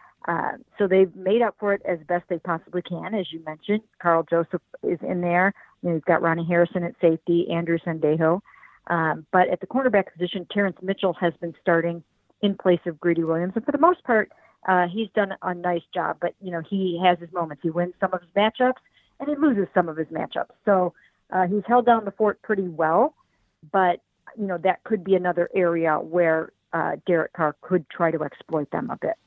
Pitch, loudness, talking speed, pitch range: 180 Hz, -24 LUFS, 215 wpm, 170-200 Hz